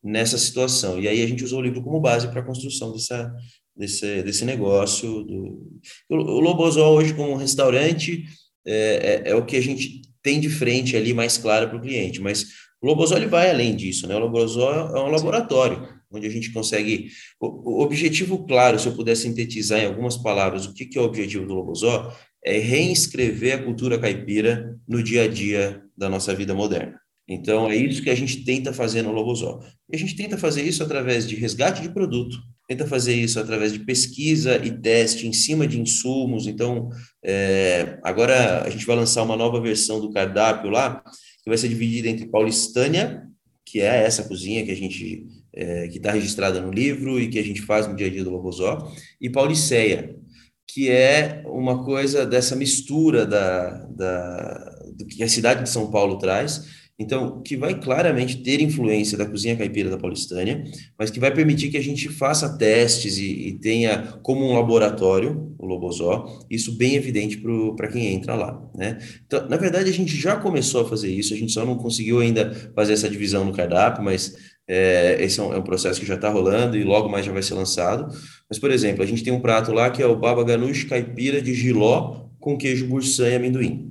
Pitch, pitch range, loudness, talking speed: 115 Hz, 105-130 Hz, -21 LUFS, 200 wpm